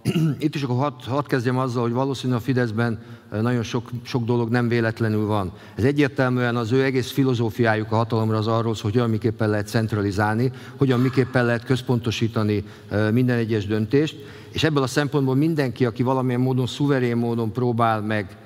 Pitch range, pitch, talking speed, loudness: 110-130 Hz, 120 Hz, 170 wpm, -22 LUFS